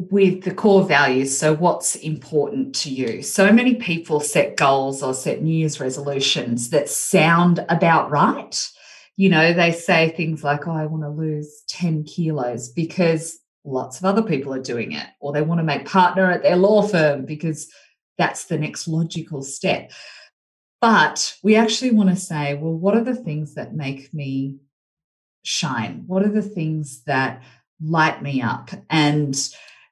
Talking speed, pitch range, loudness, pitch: 170 wpm, 145-185 Hz, -20 LUFS, 160 Hz